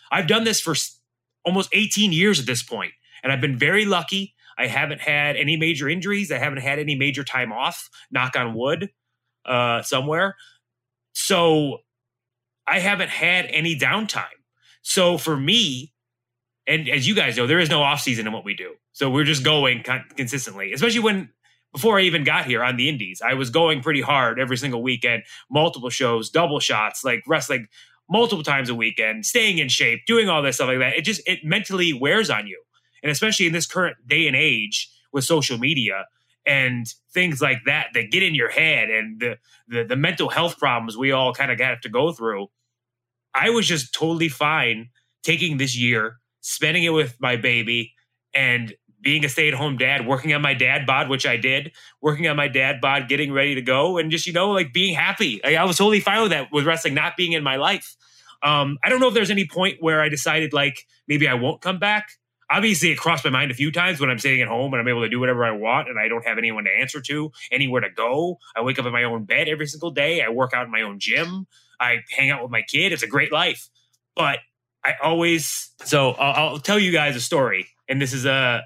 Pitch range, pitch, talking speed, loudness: 125-165 Hz, 145 Hz, 220 wpm, -20 LUFS